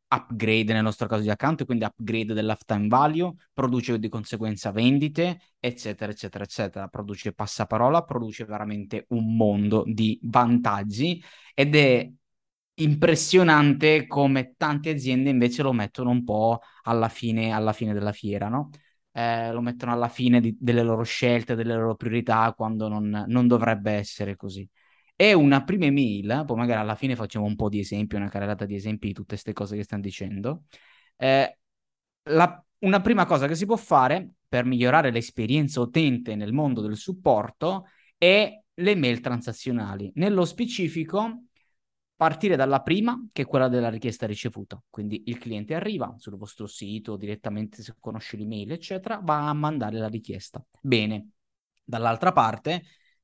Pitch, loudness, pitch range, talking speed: 120 Hz, -24 LUFS, 110-145 Hz, 155 wpm